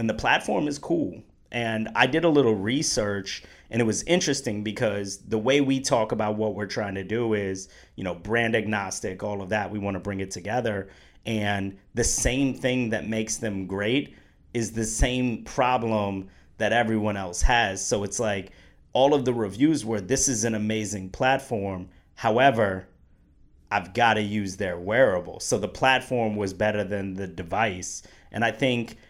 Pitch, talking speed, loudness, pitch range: 105 Hz, 180 wpm, -25 LUFS, 95-120 Hz